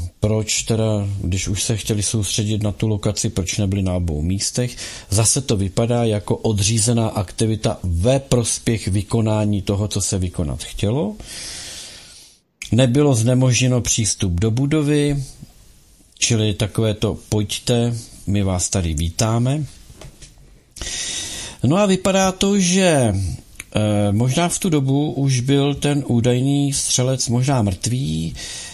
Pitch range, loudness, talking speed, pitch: 100-130 Hz, -19 LUFS, 125 wpm, 115 Hz